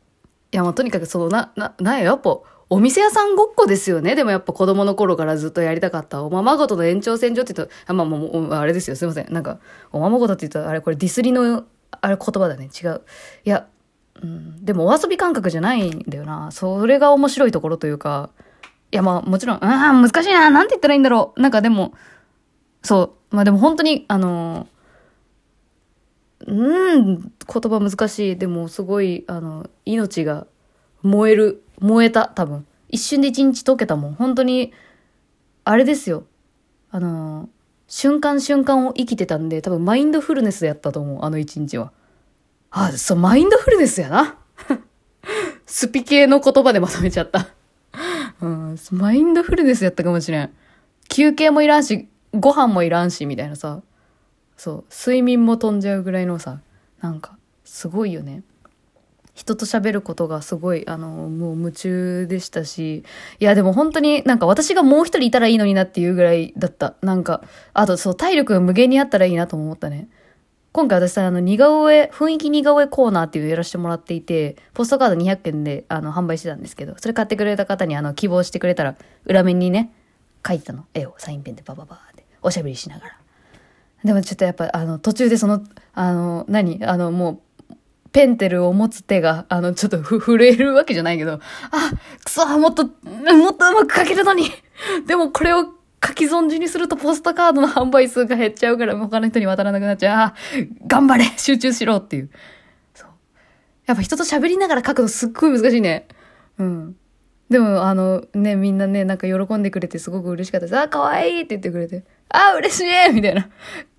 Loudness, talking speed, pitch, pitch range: -17 LUFS, 385 characters per minute, 205 Hz, 175-265 Hz